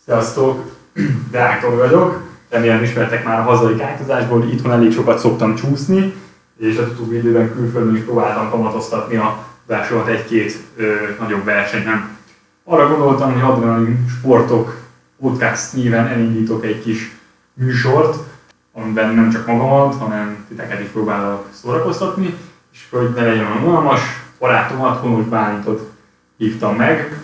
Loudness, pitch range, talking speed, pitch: -16 LUFS, 110-130 Hz, 125 wpm, 115 Hz